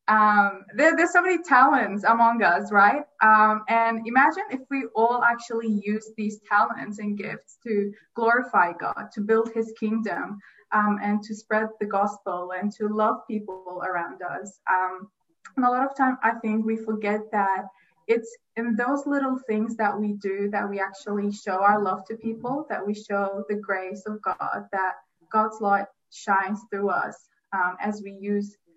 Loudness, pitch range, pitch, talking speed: -24 LUFS, 200-230 Hz, 210 Hz, 175 wpm